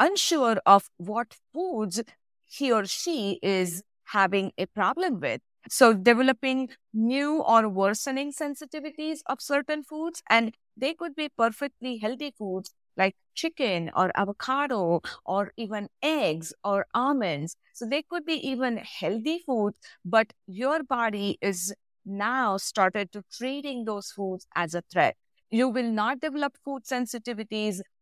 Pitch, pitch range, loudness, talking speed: 230 Hz, 200-280 Hz, -27 LUFS, 135 wpm